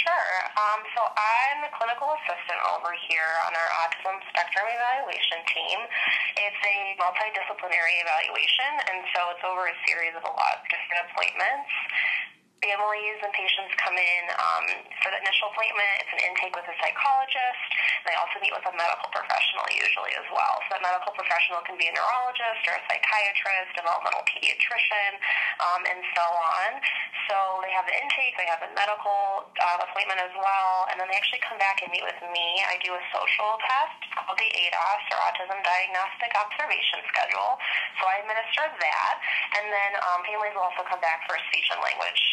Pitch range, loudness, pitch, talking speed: 180-215 Hz, -25 LUFS, 195 Hz, 185 wpm